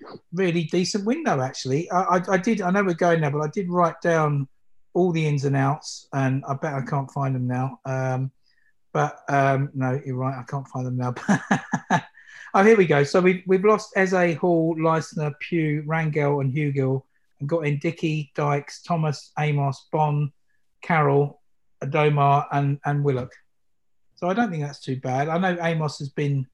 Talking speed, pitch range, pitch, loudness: 185 wpm, 135-170 Hz, 145 Hz, -23 LUFS